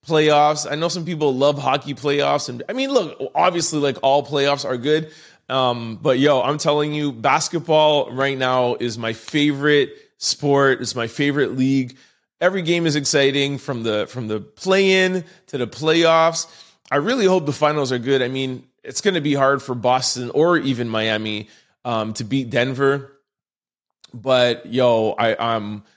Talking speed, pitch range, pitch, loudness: 170 wpm, 125-155 Hz, 140 Hz, -19 LUFS